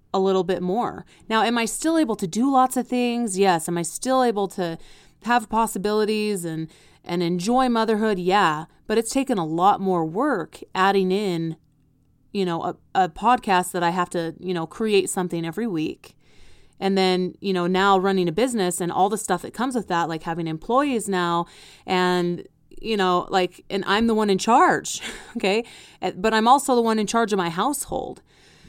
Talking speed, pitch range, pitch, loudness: 190 wpm, 180-225 Hz, 195 Hz, -22 LUFS